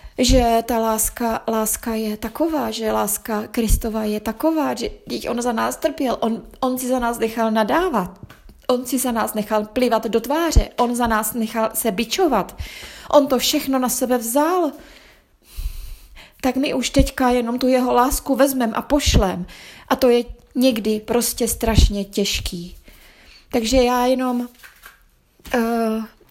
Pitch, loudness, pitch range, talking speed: 240 Hz, -20 LUFS, 225-260 Hz, 150 wpm